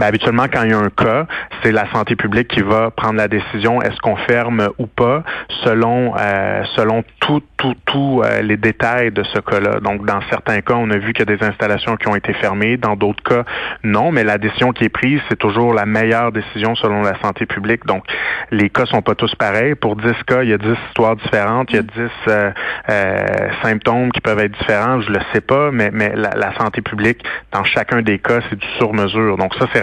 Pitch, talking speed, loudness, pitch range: 110 Hz, 235 wpm, -16 LUFS, 105-120 Hz